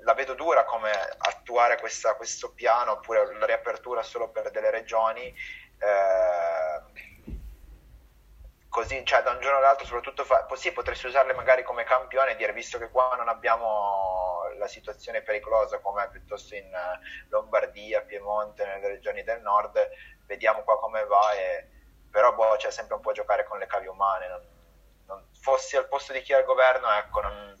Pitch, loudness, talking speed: 130 Hz, -26 LUFS, 170 wpm